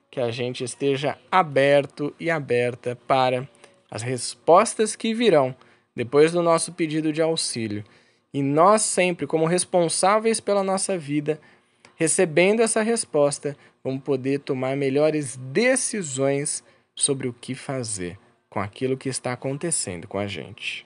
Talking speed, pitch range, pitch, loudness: 130 wpm, 125-170 Hz, 140 Hz, -23 LUFS